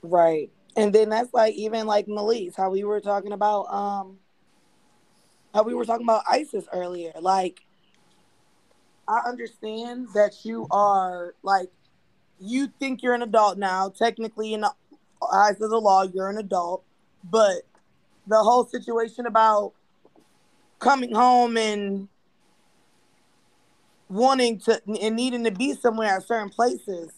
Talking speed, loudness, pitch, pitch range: 135 wpm, -23 LUFS, 215 Hz, 195-235 Hz